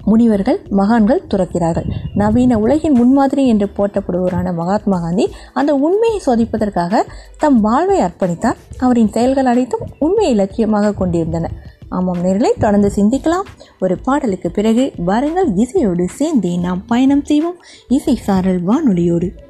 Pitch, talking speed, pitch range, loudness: 220 Hz, 115 wpm, 190-270 Hz, -15 LUFS